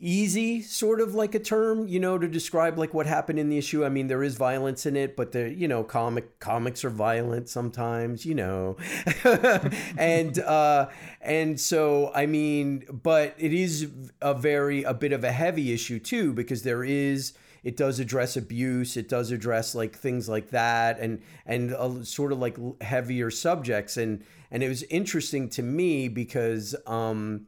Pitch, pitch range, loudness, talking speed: 135 Hz, 120-155 Hz, -27 LUFS, 180 wpm